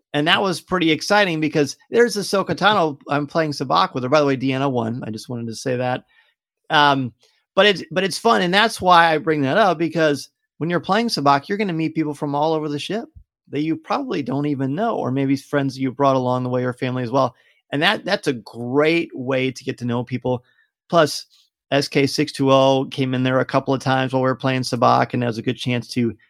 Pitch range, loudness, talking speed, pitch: 130-170 Hz, -20 LUFS, 235 wpm, 145 Hz